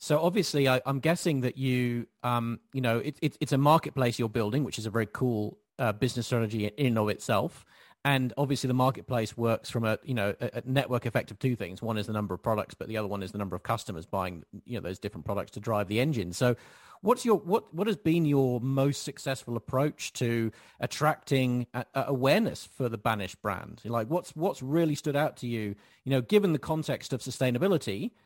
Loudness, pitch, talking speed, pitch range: -30 LUFS, 125 Hz, 225 wpm, 110-140 Hz